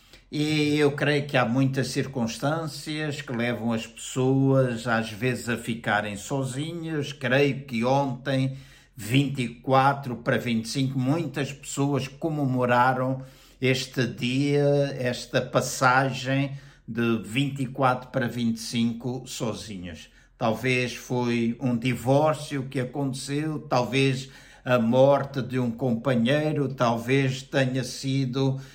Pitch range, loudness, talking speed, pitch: 120-140 Hz, -25 LUFS, 100 wpm, 130 Hz